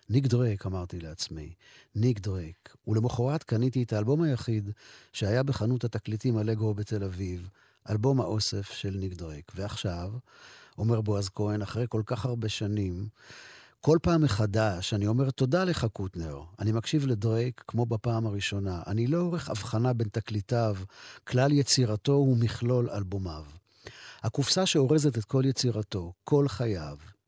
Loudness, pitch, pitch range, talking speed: -29 LUFS, 110 Hz, 100-125 Hz, 135 wpm